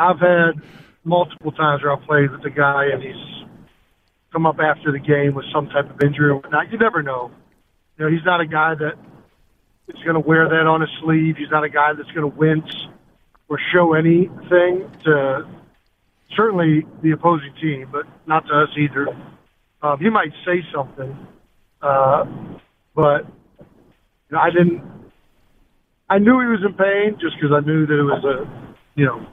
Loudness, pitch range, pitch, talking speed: -18 LUFS, 145-170 Hz, 155 Hz, 180 wpm